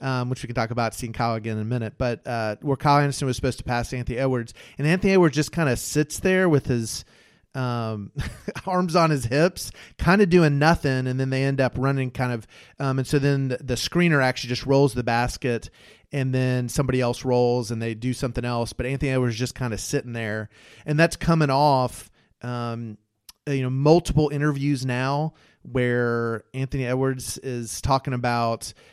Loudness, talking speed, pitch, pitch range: -23 LUFS, 200 wpm, 130 Hz, 120-140 Hz